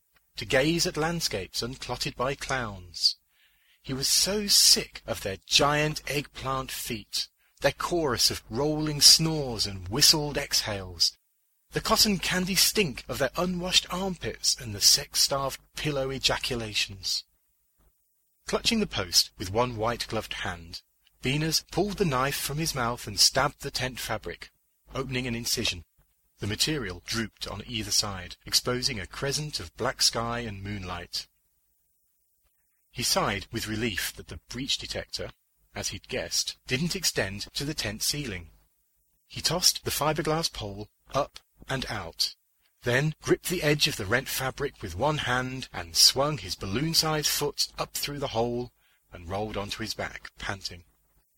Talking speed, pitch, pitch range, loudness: 145 wpm, 120 Hz, 100-150 Hz, -26 LUFS